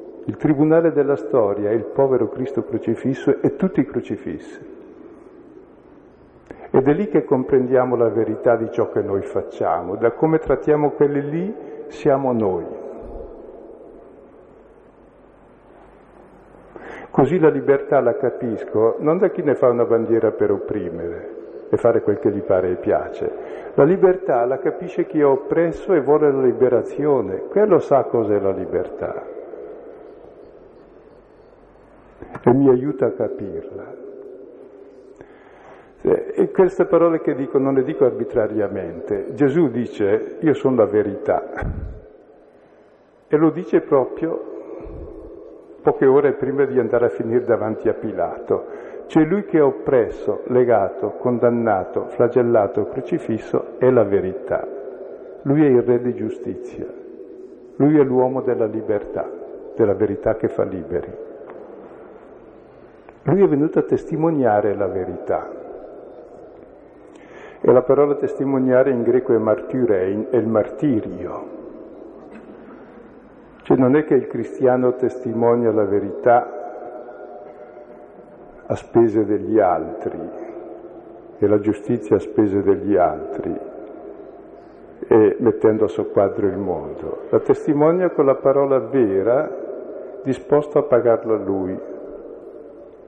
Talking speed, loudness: 120 wpm, -19 LUFS